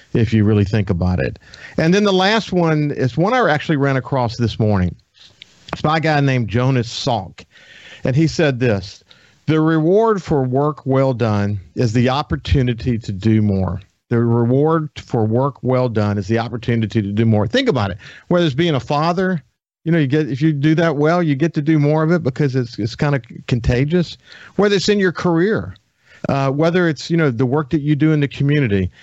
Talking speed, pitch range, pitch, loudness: 210 wpm, 115-160 Hz, 140 Hz, -17 LUFS